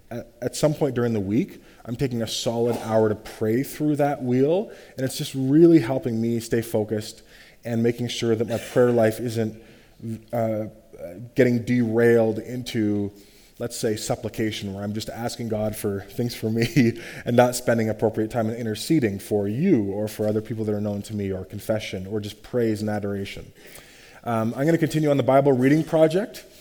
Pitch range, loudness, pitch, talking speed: 110-125 Hz, -23 LUFS, 115 Hz, 185 wpm